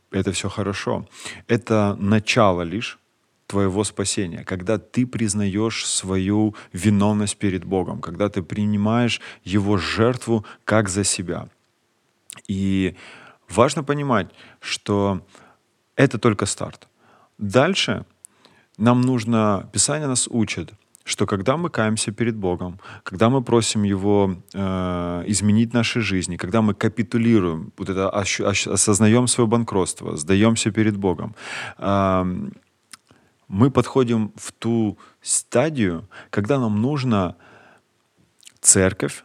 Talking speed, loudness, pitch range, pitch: 110 wpm, -21 LUFS, 95-115 Hz, 105 Hz